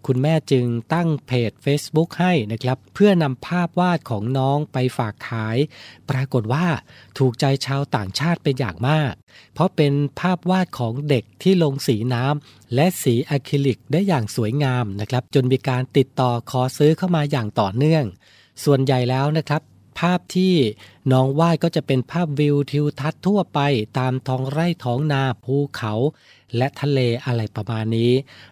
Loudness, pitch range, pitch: -21 LUFS, 120-155 Hz, 135 Hz